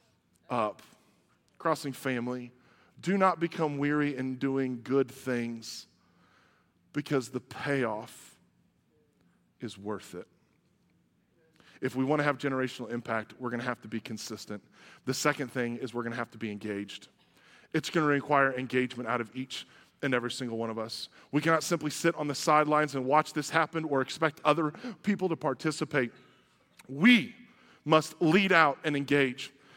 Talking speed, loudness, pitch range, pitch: 160 wpm, -30 LUFS, 120-155 Hz, 135 Hz